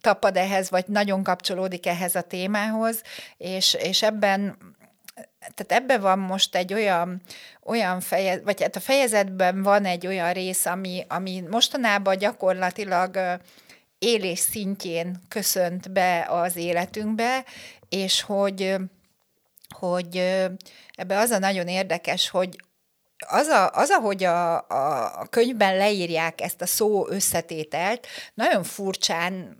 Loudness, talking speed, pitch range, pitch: -23 LUFS, 120 wpm, 180-205 Hz, 190 Hz